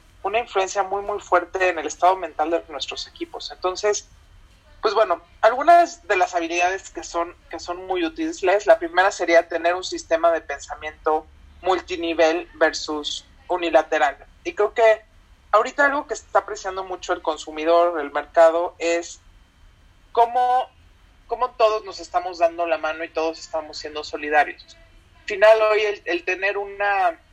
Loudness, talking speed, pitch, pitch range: -21 LUFS, 150 wpm, 175 Hz, 160-210 Hz